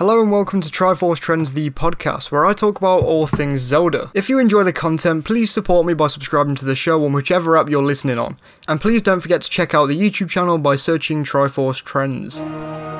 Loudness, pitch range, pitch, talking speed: -17 LUFS, 145-185 Hz, 160 Hz, 220 wpm